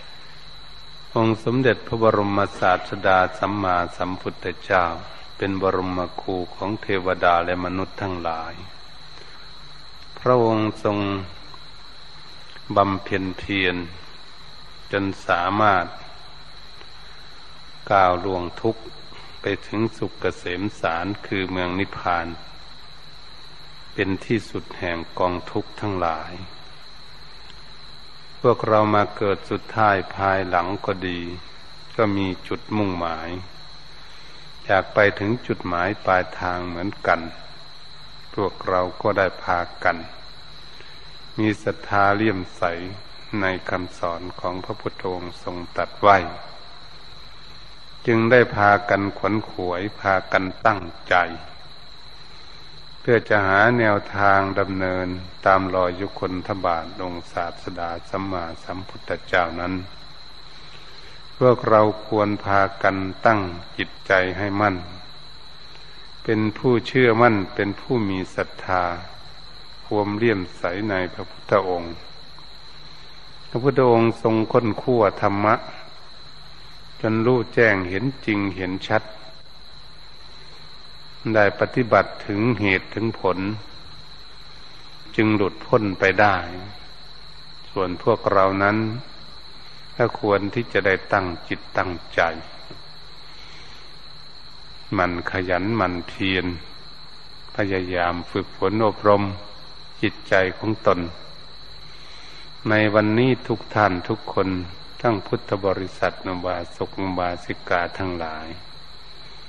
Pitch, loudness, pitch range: 95 Hz, -22 LUFS, 90-105 Hz